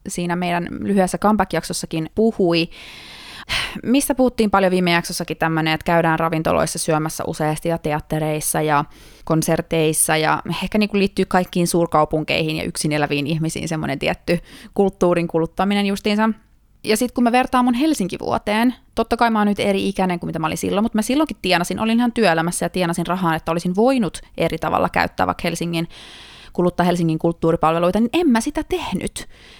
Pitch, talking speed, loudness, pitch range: 175 Hz, 165 wpm, -19 LUFS, 165-210 Hz